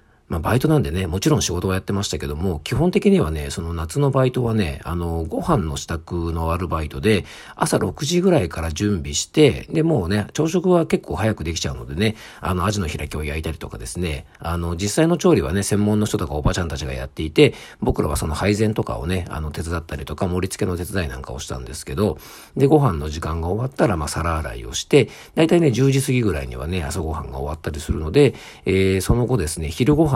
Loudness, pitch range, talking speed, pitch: -21 LUFS, 80-115 Hz, 445 characters per minute, 90 Hz